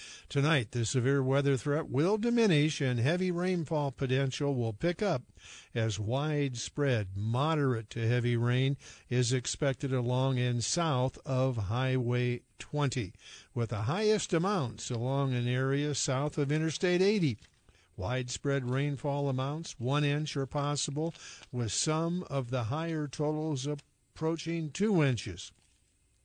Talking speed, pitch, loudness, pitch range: 125 wpm, 140 Hz, -31 LUFS, 125-155 Hz